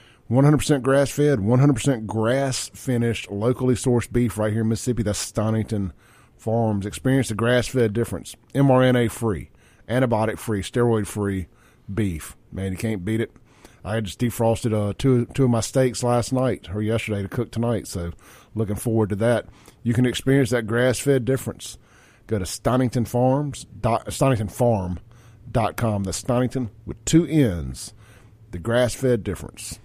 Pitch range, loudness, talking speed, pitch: 105-125 Hz, -22 LUFS, 130 wpm, 115 Hz